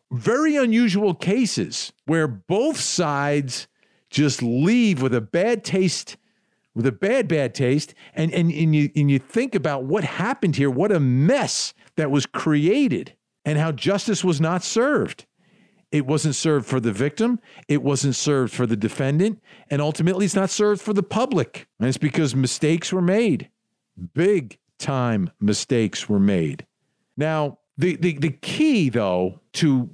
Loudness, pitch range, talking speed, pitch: -22 LUFS, 135-200 Hz, 155 wpm, 155 Hz